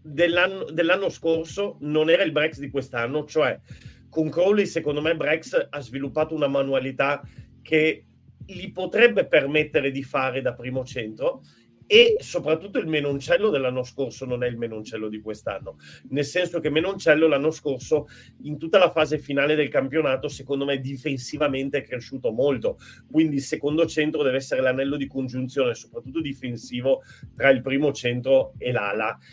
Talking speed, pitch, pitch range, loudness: 155 wpm, 145 Hz, 135-160 Hz, -23 LUFS